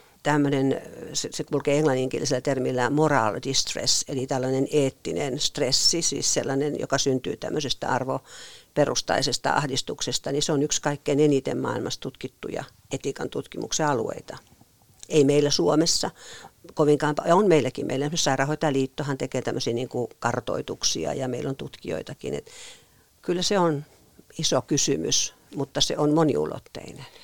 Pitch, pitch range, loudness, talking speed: 145 Hz, 135-150 Hz, -25 LUFS, 125 wpm